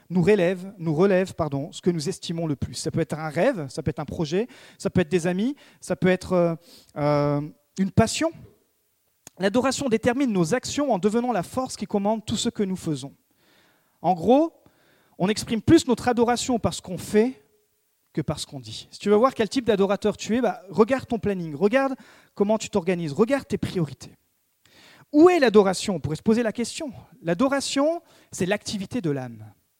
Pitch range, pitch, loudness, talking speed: 170-240 Hz, 200 Hz, -24 LUFS, 195 wpm